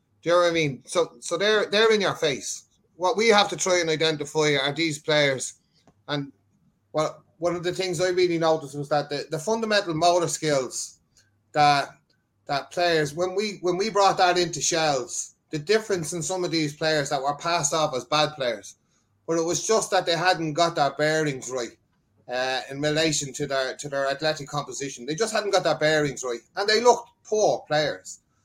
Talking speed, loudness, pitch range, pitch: 200 wpm, -24 LUFS, 145-180 Hz, 160 Hz